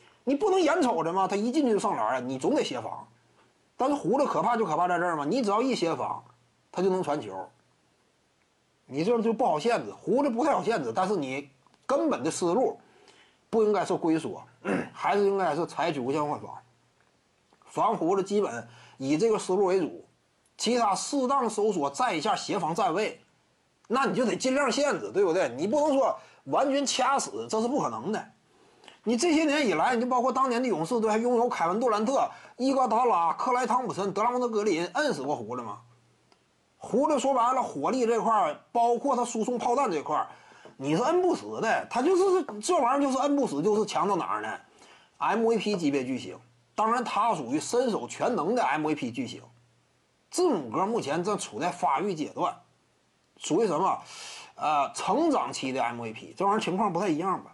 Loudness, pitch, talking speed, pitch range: -27 LUFS, 235 Hz, 290 characters per minute, 190-270 Hz